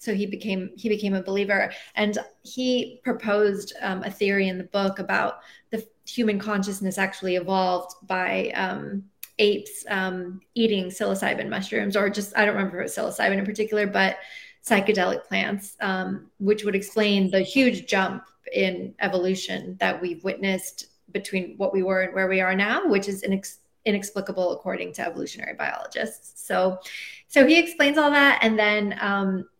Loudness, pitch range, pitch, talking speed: -24 LUFS, 190-215 Hz, 200 Hz, 165 wpm